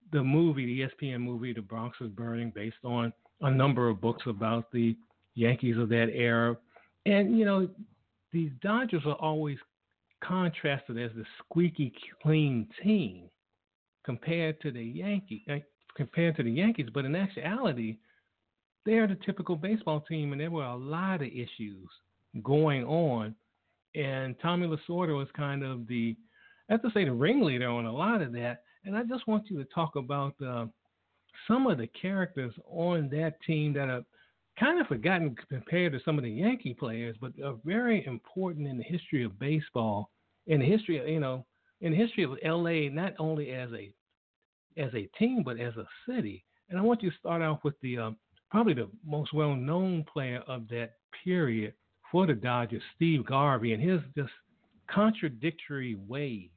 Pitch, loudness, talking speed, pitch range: 145 Hz, -31 LUFS, 175 wpm, 120-175 Hz